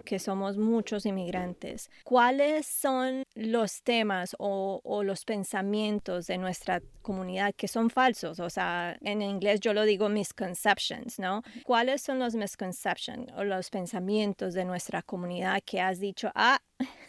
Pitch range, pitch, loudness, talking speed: 190-230 Hz, 205 Hz, -30 LUFS, 145 wpm